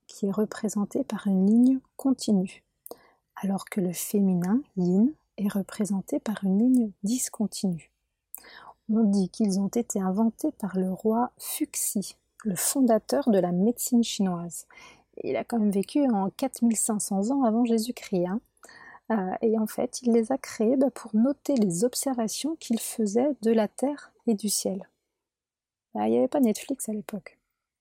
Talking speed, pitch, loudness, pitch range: 155 wpm, 220 Hz, -26 LUFS, 200-250 Hz